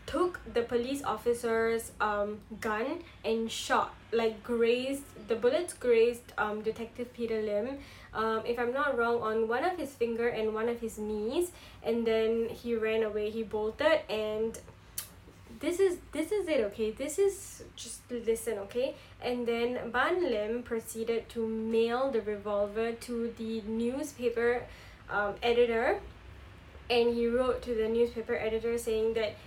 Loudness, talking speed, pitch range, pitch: -32 LUFS, 150 wpm, 220-245 Hz, 230 Hz